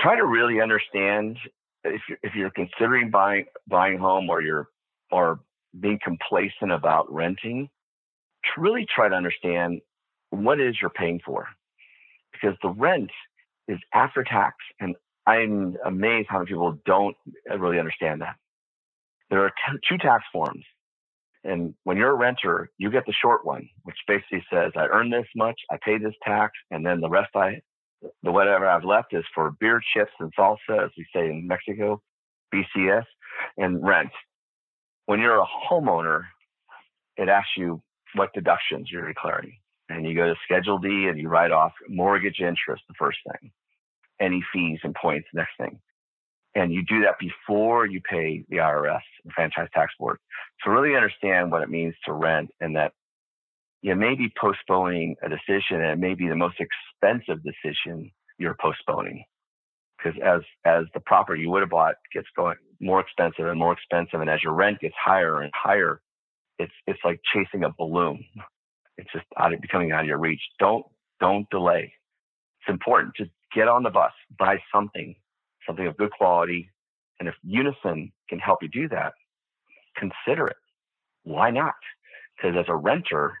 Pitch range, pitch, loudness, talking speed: 85-105 Hz, 95 Hz, -24 LUFS, 170 wpm